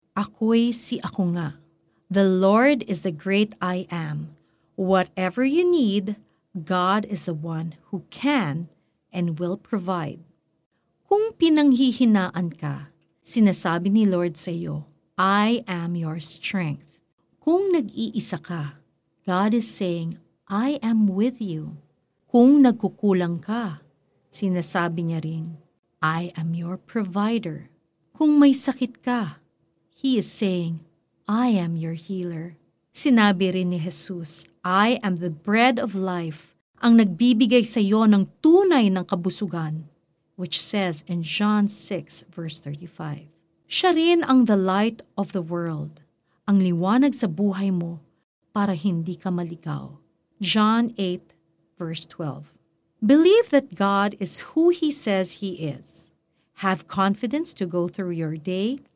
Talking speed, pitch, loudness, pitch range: 130 wpm, 185 Hz, -22 LUFS, 165-215 Hz